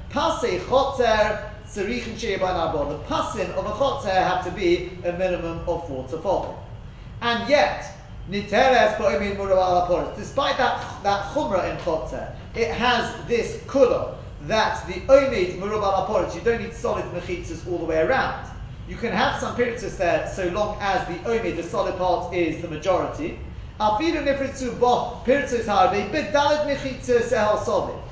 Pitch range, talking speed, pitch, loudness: 180-250 Hz, 115 wpm, 200 Hz, -23 LUFS